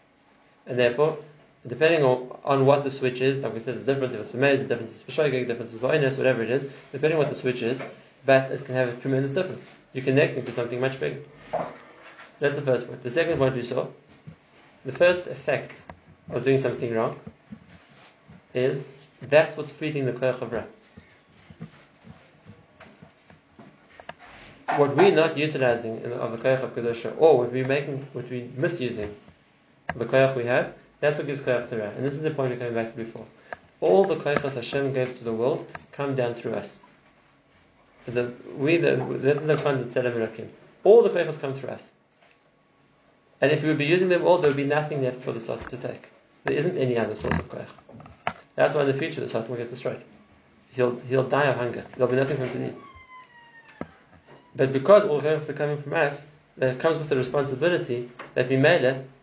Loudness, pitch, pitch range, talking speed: -25 LUFS, 135 Hz, 125-145 Hz, 200 wpm